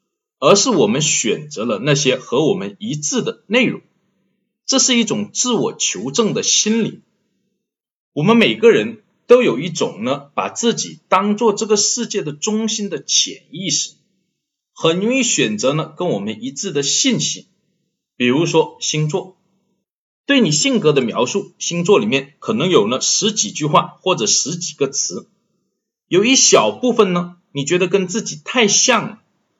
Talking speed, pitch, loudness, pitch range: 230 characters per minute, 205 Hz, -16 LUFS, 175-230 Hz